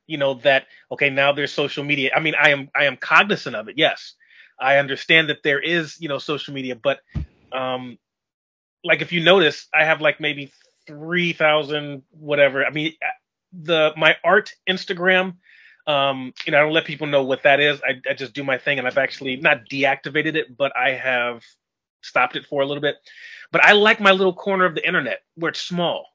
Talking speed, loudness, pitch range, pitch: 205 wpm, -19 LUFS, 135-160 Hz, 145 Hz